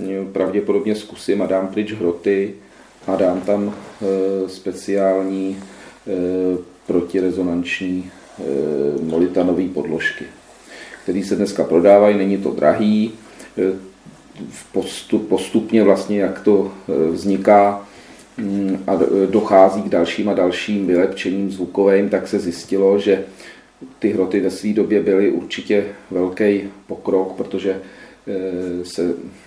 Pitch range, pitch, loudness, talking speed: 90-100 Hz, 95 Hz, -18 LUFS, 100 wpm